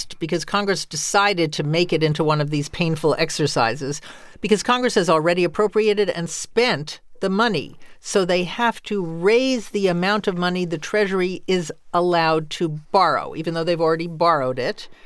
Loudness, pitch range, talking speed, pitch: -21 LUFS, 160-205 Hz, 165 wpm, 175 Hz